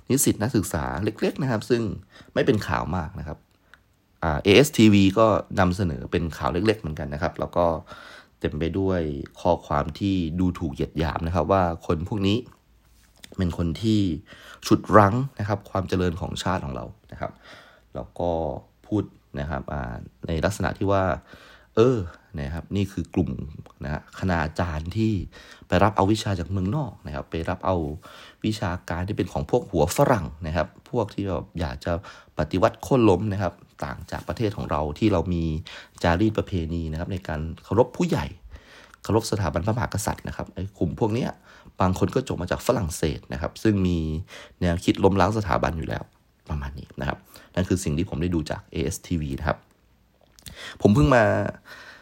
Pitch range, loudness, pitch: 80-100 Hz, -25 LUFS, 90 Hz